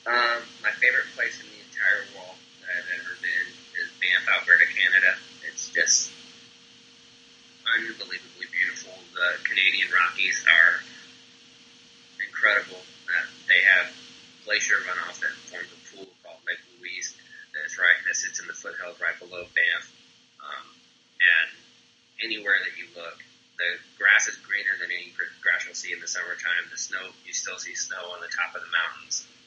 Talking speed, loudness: 155 wpm, -24 LUFS